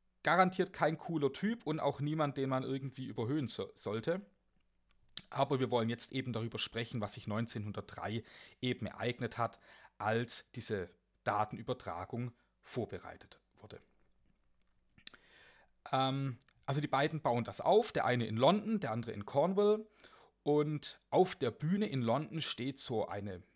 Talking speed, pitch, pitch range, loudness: 140 wpm, 130 Hz, 115-150 Hz, -36 LUFS